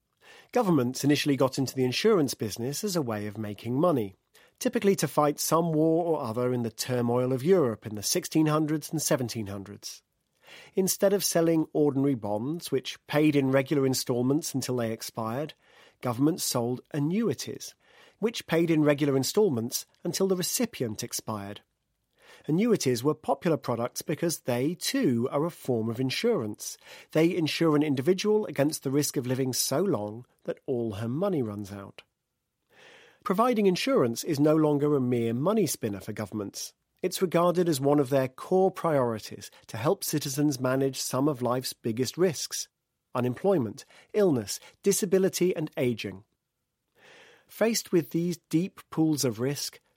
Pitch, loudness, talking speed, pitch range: 145 Hz, -27 LUFS, 150 wpm, 125-175 Hz